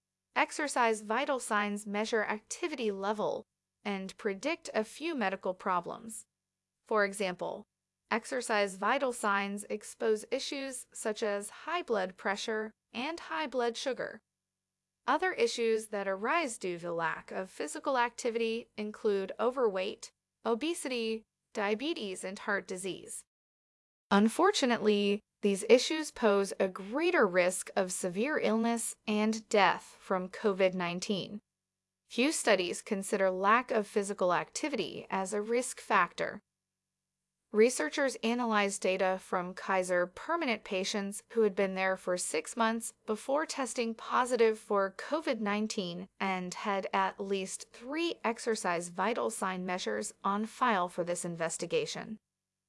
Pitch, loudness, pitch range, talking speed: 215 Hz, -32 LUFS, 190-240 Hz, 120 wpm